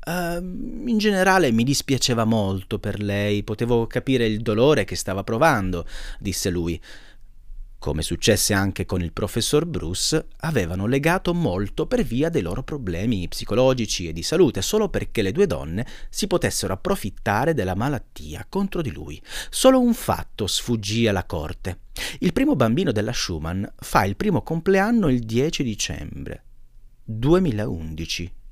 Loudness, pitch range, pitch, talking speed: -22 LUFS, 95-155 Hz, 115 Hz, 145 wpm